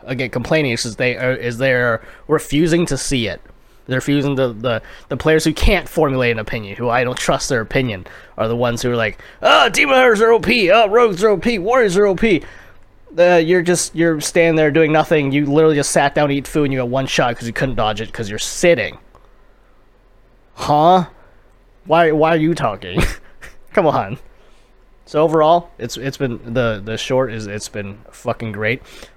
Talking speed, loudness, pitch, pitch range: 200 wpm, -16 LUFS, 135 Hz, 120-165 Hz